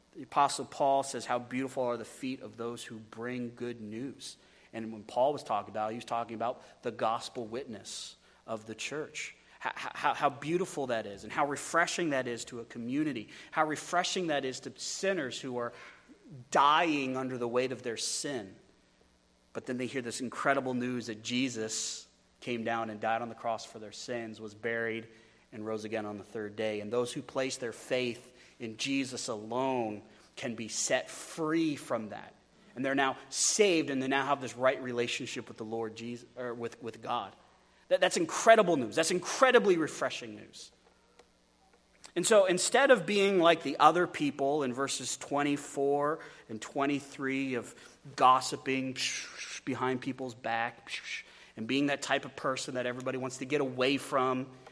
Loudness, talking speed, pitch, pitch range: -32 LUFS, 180 wpm, 130 Hz, 115-140 Hz